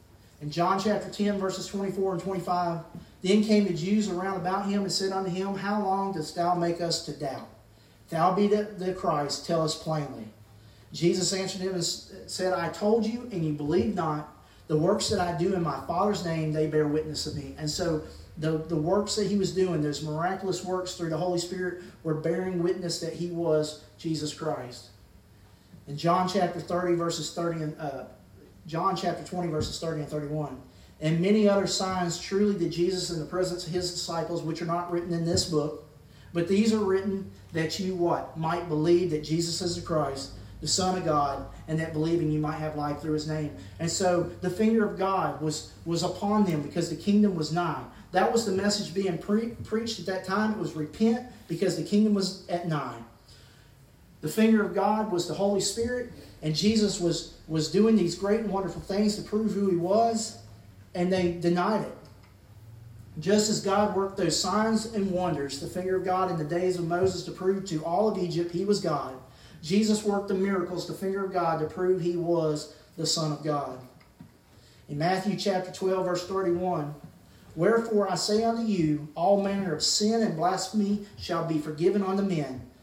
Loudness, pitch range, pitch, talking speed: -28 LUFS, 155-195 Hz, 175 Hz, 200 wpm